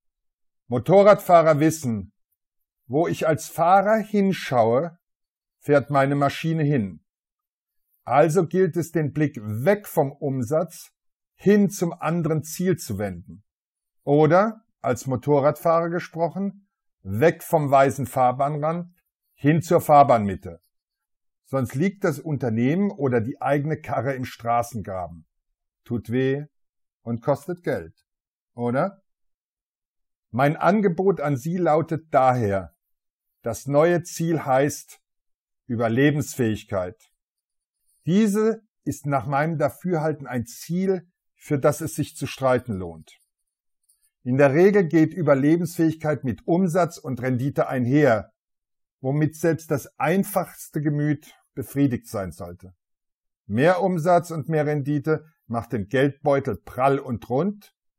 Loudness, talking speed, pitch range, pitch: -22 LUFS, 110 wpm, 125-170 Hz, 145 Hz